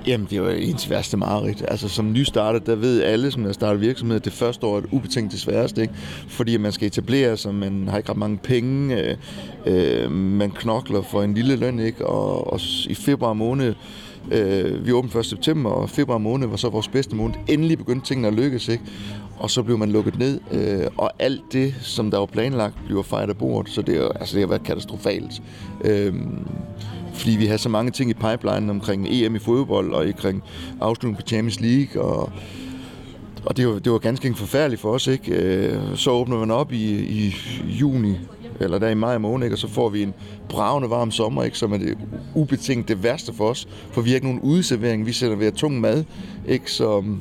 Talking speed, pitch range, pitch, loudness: 215 wpm, 105-125 Hz, 115 Hz, -22 LUFS